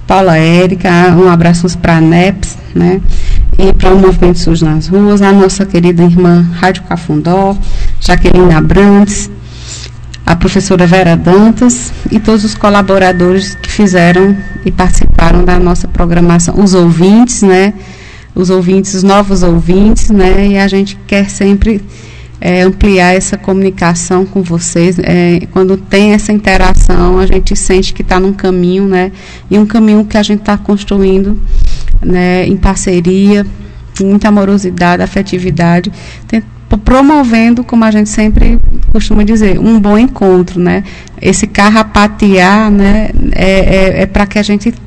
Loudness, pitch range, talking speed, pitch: -8 LUFS, 180-205 Hz, 145 wpm, 190 Hz